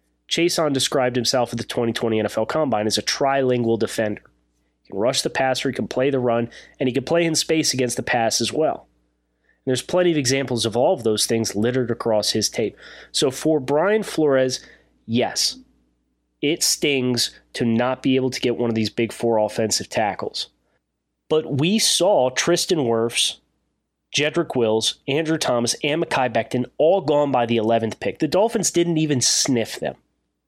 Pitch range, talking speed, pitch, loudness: 110-145 Hz, 180 wpm, 125 Hz, -21 LUFS